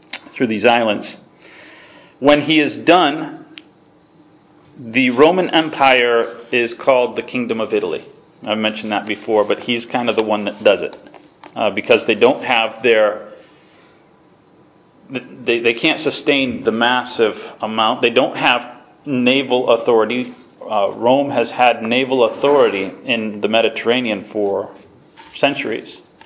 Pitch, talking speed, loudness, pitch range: 125 Hz, 135 wpm, -16 LUFS, 115-155 Hz